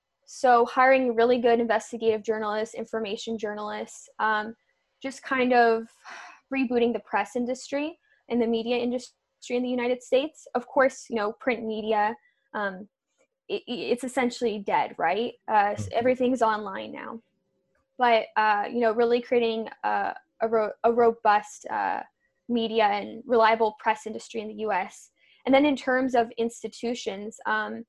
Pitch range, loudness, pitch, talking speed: 220-255 Hz, -26 LUFS, 235 Hz, 145 wpm